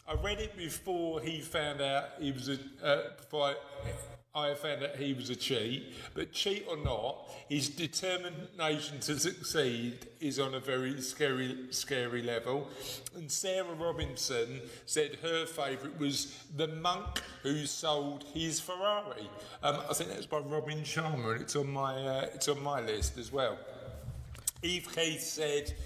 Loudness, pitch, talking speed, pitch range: -35 LUFS, 145 Hz, 160 wpm, 135-160 Hz